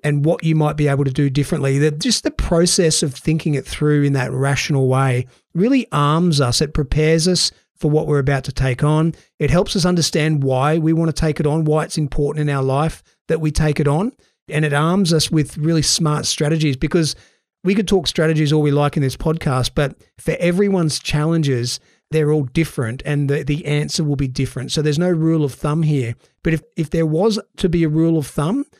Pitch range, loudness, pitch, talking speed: 145-165 Hz, -18 LUFS, 155 Hz, 220 wpm